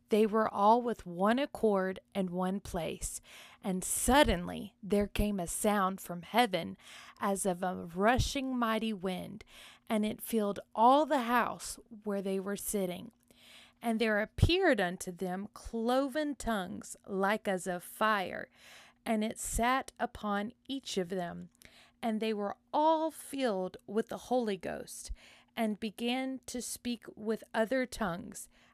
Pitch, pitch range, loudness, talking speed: 220 Hz, 195-240 Hz, -33 LUFS, 140 wpm